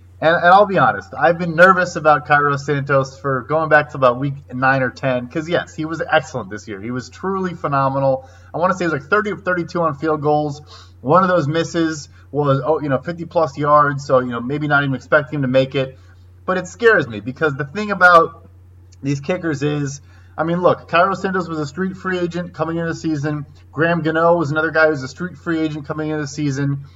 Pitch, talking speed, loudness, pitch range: 150 Hz, 235 wpm, -17 LUFS, 130-165 Hz